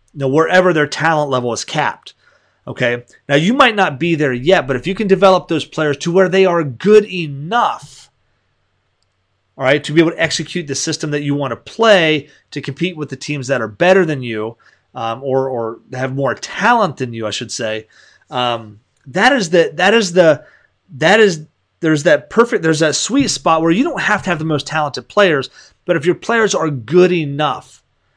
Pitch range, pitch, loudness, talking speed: 130-180 Hz, 155 Hz, -15 LUFS, 205 wpm